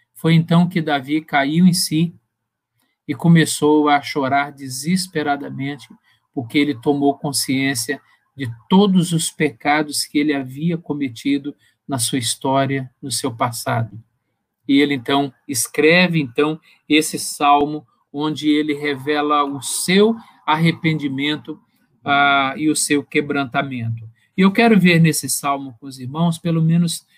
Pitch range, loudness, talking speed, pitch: 135-160 Hz, -18 LUFS, 130 wpm, 145 Hz